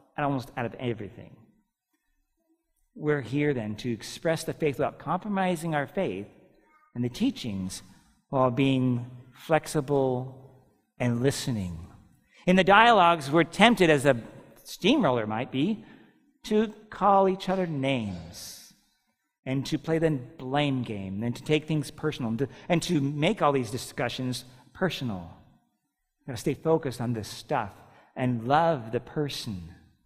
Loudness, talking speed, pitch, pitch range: -27 LUFS, 140 wpm, 140 Hz, 120-165 Hz